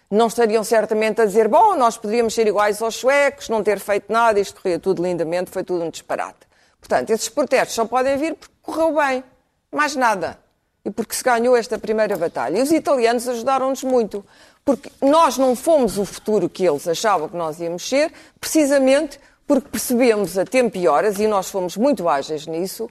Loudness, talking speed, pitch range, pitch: -19 LUFS, 190 wpm, 200-265 Hz, 225 Hz